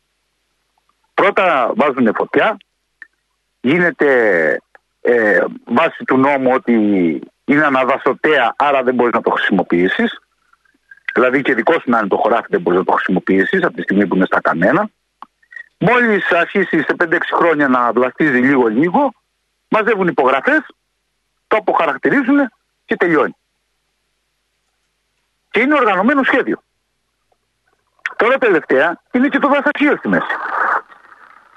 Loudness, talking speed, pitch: -15 LUFS, 120 wpm, 285 Hz